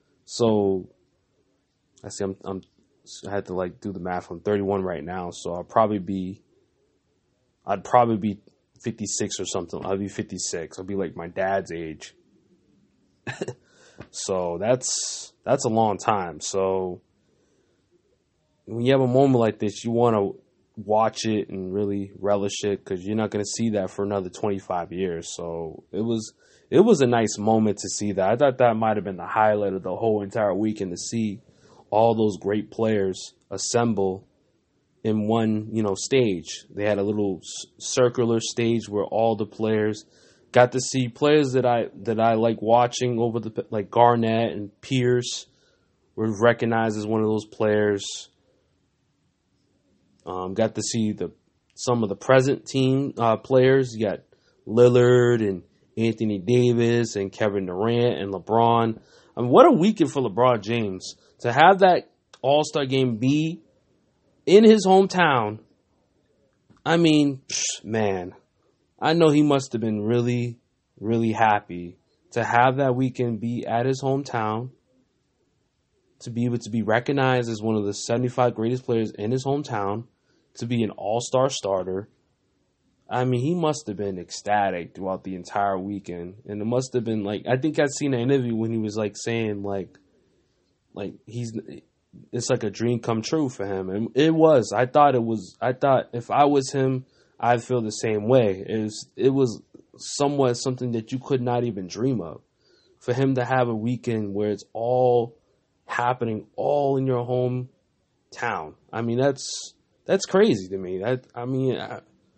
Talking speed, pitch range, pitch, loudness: 170 wpm, 100-125 Hz, 115 Hz, -23 LUFS